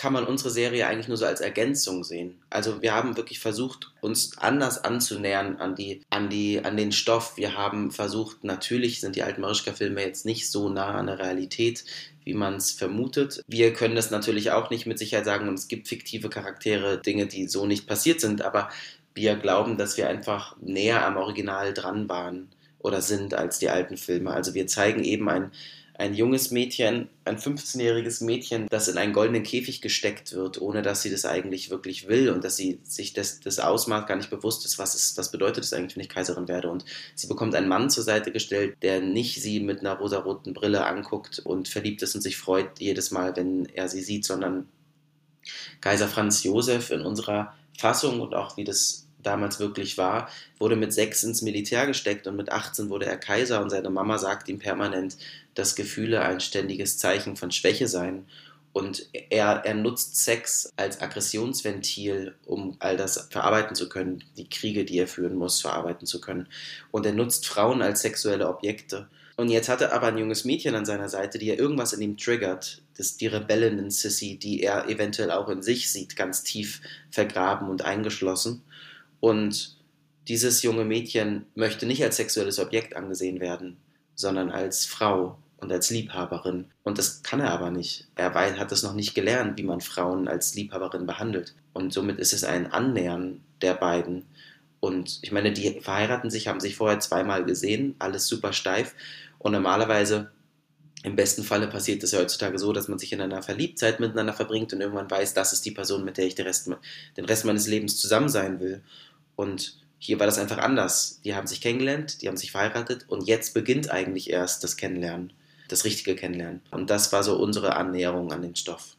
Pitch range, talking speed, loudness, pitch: 95-115 Hz, 195 wpm, -26 LUFS, 100 Hz